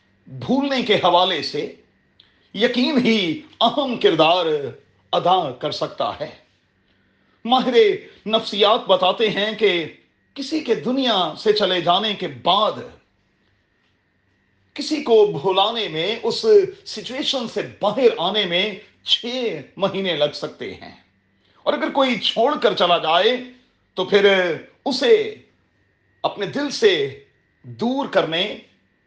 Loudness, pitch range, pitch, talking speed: -19 LUFS, 185-280 Hz, 225 Hz, 115 wpm